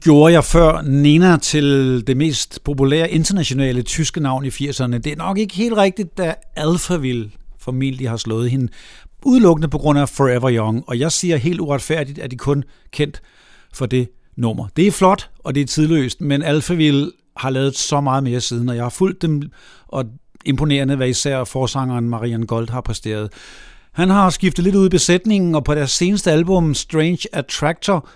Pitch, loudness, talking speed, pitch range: 145 Hz, -17 LUFS, 185 wpm, 130-165 Hz